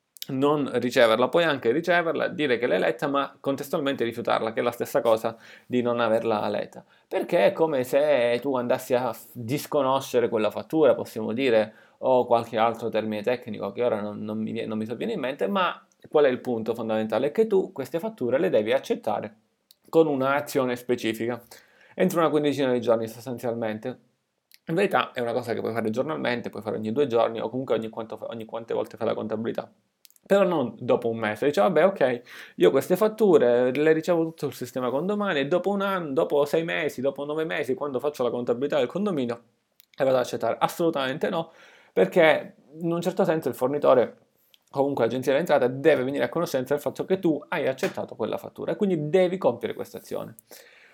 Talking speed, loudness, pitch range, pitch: 190 wpm, -25 LUFS, 115-155 Hz, 130 Hz